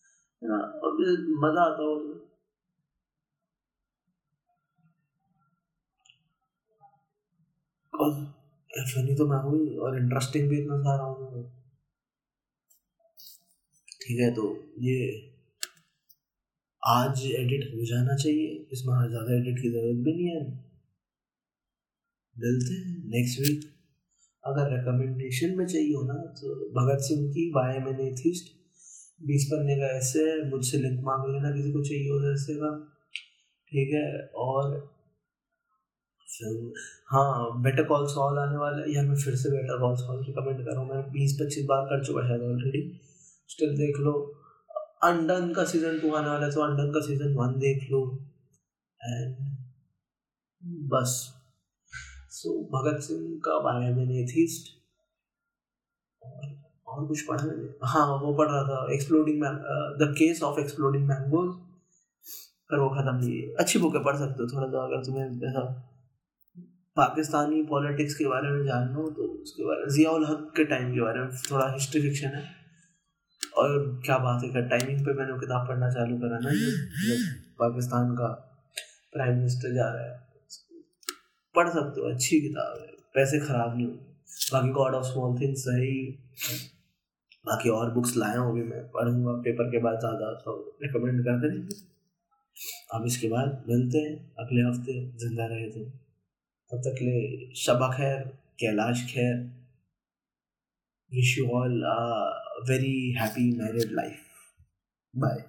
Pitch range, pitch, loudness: 125-155 Hz, 140 Hz, -28 LUFS